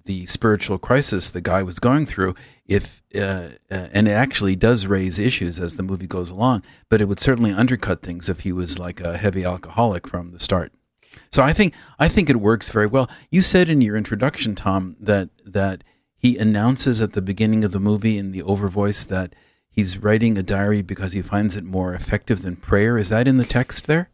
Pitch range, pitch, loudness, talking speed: 95-120 Hz, 105 Hz, -20 LUFS, 215 wpm